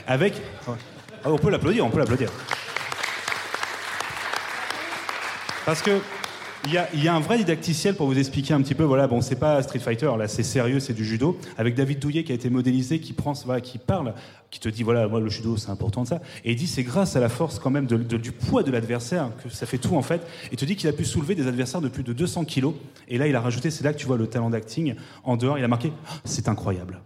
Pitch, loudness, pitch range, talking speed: 135 Hz, -25 LUFS, 120-155 Hz, 255 wpm